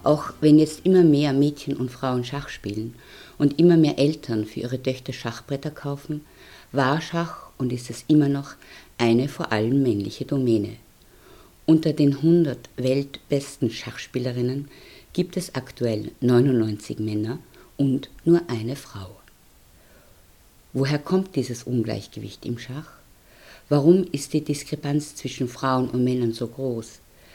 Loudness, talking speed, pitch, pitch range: -23 LUFS, 135 wpm, 130 Hz, 120-145 Hz